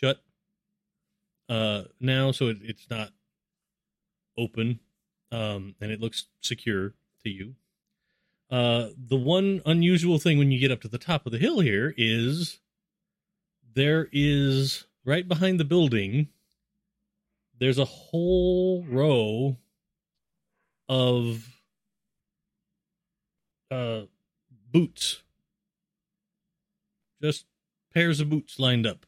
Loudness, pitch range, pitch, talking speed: -26 LUFS, 125-190 Hz, 160 Hz, 105 wpm